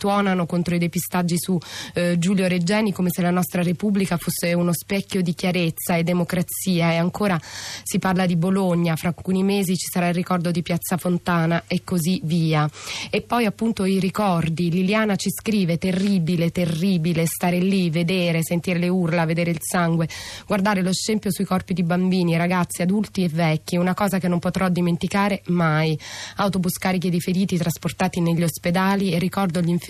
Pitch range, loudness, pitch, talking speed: 170-190 Hz, -22 LUFS, 180 Hz, 175 wpm